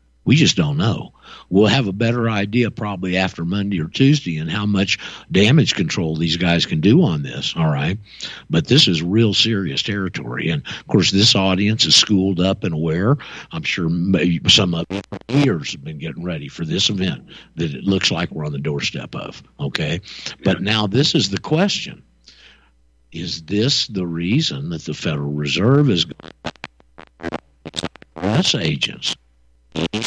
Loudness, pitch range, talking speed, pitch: -18 LUFS, 80-110 Hz, 165 wpm, 95 Hz